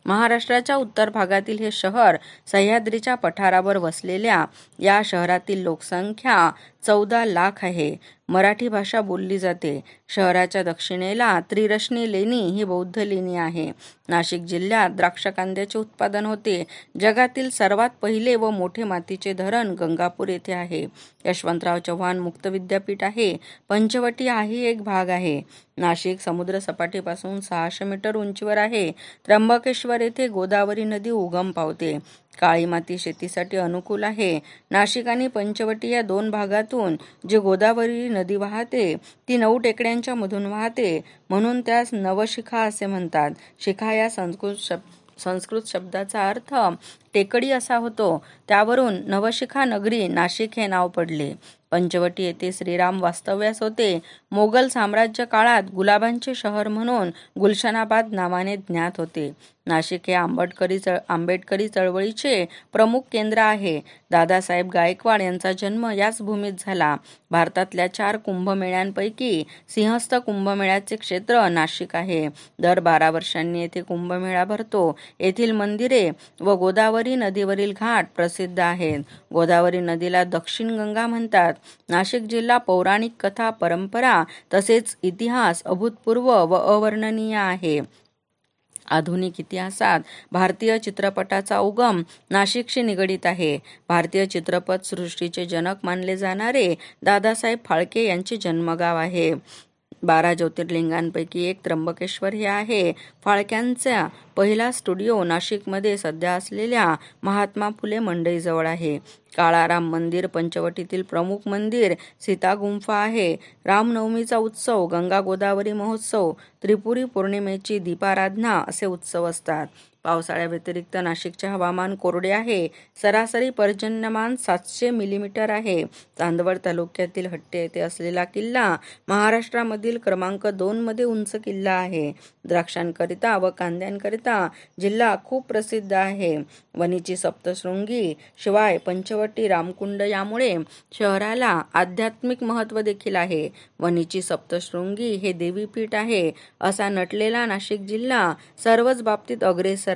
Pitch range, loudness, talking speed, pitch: 175-220 Hz, -22 LUFS, 110 wpm, 195 Hz